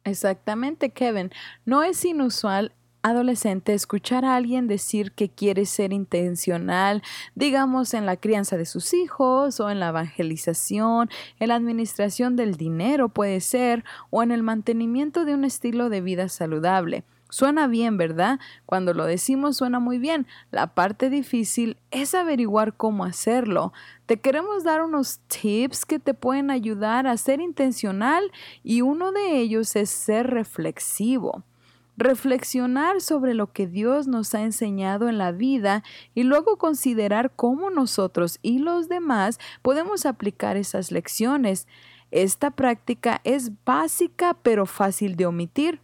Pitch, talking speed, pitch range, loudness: 235 Hz, 140 wpm, 200-270 Hz, -23 LUFS